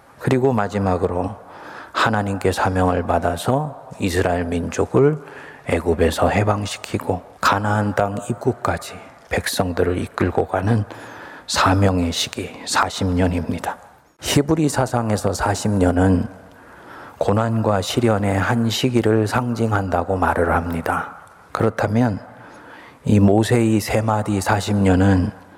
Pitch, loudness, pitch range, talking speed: 100 Hz, -20 LUFS, 95-115 Hz, 240 characters per minute